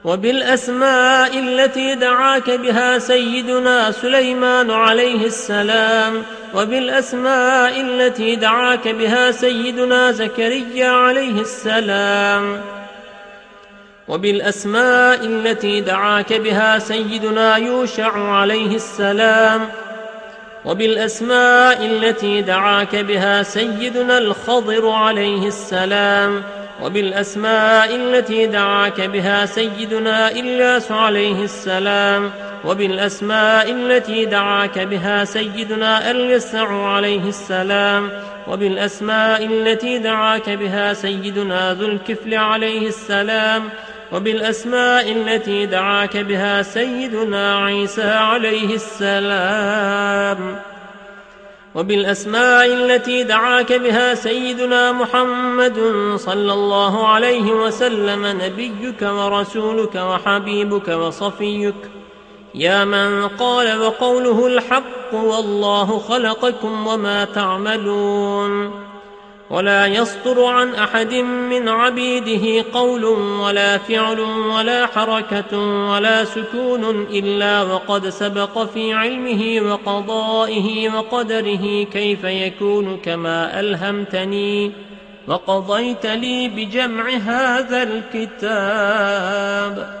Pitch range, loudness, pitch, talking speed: 200-235 Hz, -16 LUFS, 220 Hz, 80 wpm